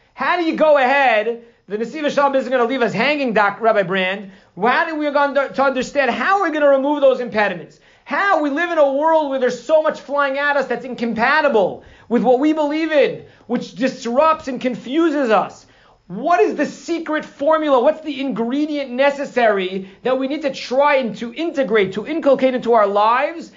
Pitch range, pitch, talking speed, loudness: 235-300 Hz, 270 Hz, 195 wpm, -17 LUFS